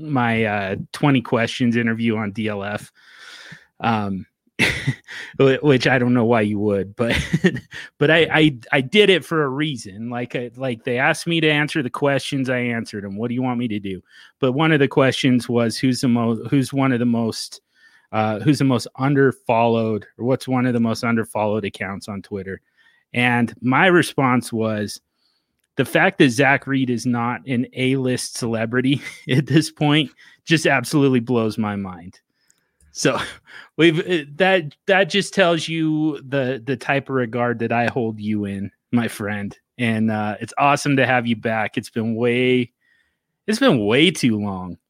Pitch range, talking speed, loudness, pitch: 110-140 Hz, 175 wpm, -19 LUFS, 125 Hz